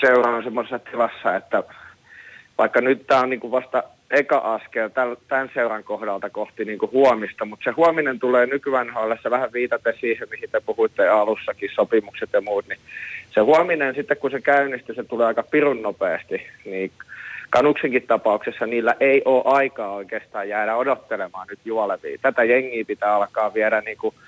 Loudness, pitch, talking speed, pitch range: -21 LUFS, 130 Hz, 160 wpm, 115-145 Hz